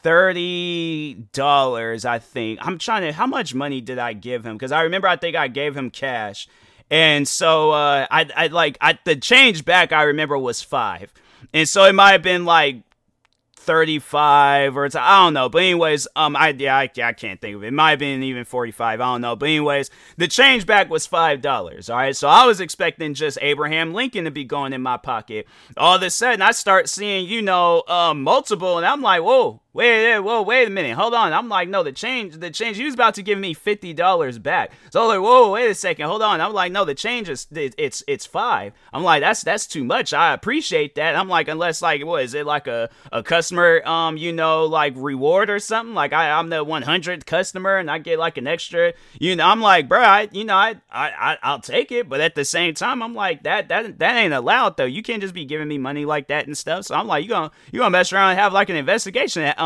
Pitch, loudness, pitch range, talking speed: 165 Hz, -18 LUFS, 145-195 Hz, 240 wpm